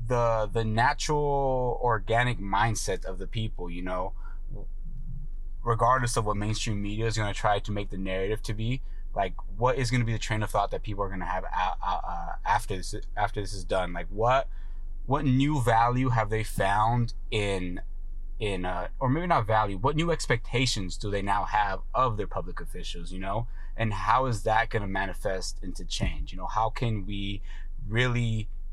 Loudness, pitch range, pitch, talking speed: -29 LUFS, 95-120 Hz, 110 Hz, 195 wpm